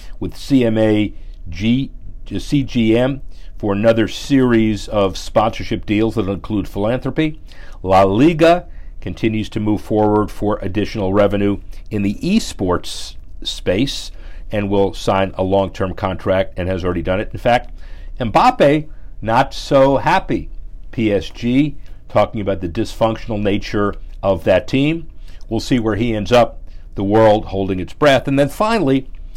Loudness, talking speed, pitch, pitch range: -17 LUFS, 135 wpm, 105 Hz, 95-115 Hz